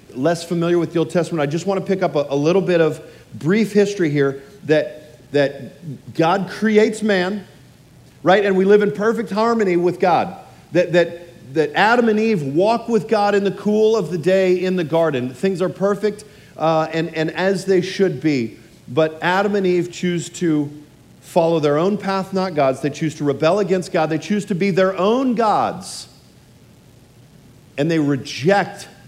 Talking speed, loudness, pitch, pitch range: 185 wpm, -18 LUFS, 175 Hz, 155-195 Hz